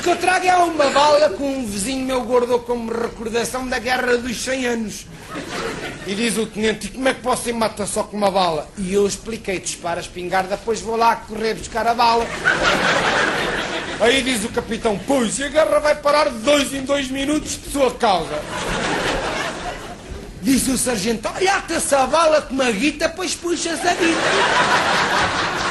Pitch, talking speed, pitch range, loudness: 245 Hz, 180 wpm, 220-285 Hz, -19 LUFS